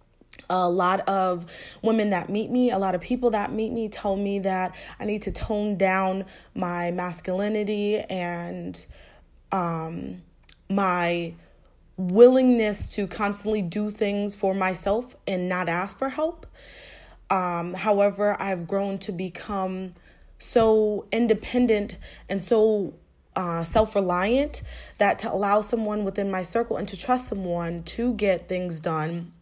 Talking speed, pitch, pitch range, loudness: 135 wpm, 195 Hz, 180-215 Hz, -25 LUFS